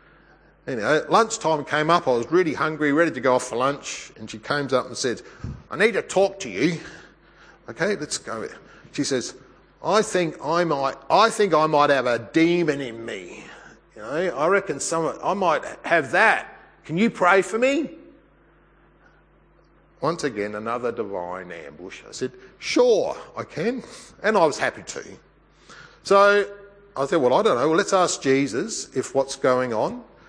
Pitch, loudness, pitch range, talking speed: 160 Hz, -22 LUFS, 135-200 Hz, 175 wpm